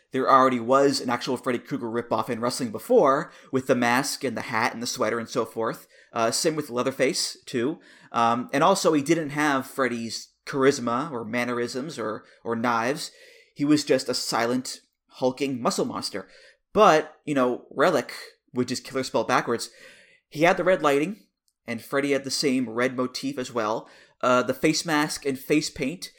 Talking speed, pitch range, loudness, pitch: 180 wpm, 120-150 Hz, -25 LUFS, 135 Hz